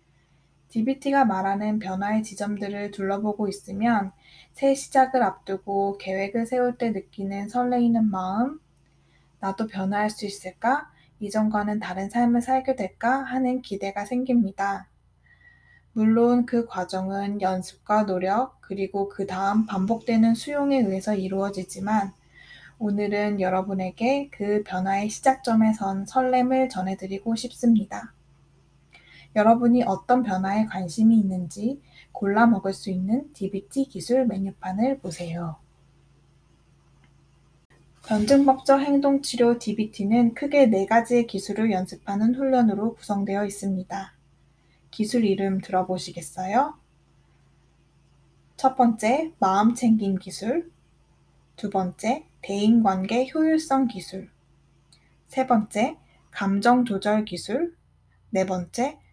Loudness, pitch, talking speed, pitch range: -24 LUFS, 210 Hz, 255 characters per minute, 195-245 Hz